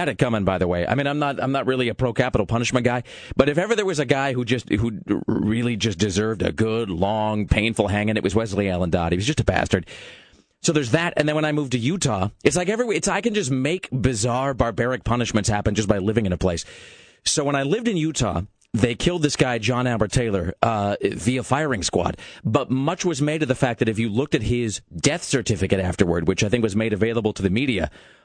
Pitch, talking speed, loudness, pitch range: 120 Hz, 245 wpm, -22 LUFS, 105-140 Hz